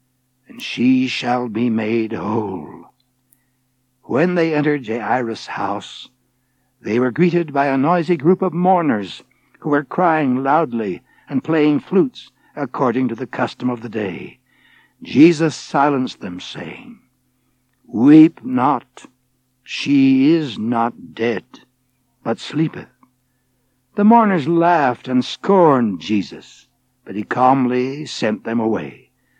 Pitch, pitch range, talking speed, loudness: 130 Hz, 120-165 Hz, 120 wpm, -17 LUFS